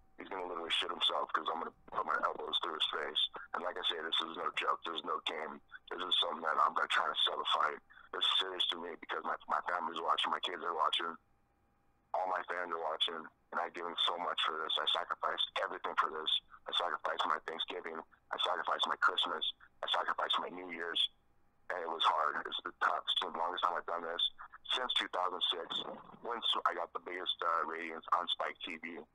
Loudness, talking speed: -35 LUFS, 230 wpm